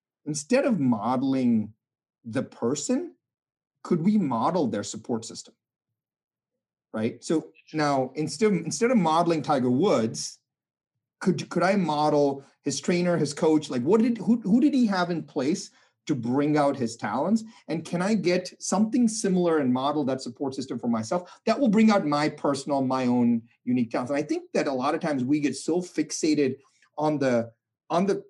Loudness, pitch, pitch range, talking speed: -25 LUFS, 155 Hz, 135-200 Hz, 175 wpm